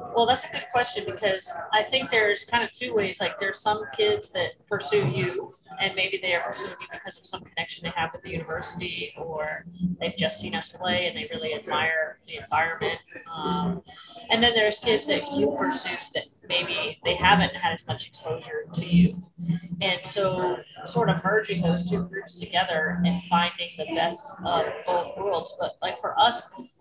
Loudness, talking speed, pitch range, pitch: -26 LUFS, 190 wpm, 170-220 Hz, 185 Hz